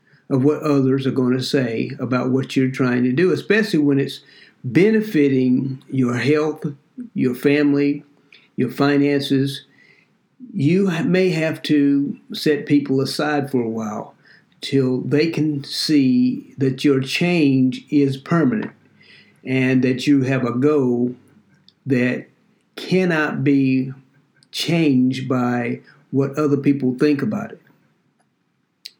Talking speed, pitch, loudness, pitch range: 120 wpm, 140 Hz, -19 LUFS, 130-150 Hz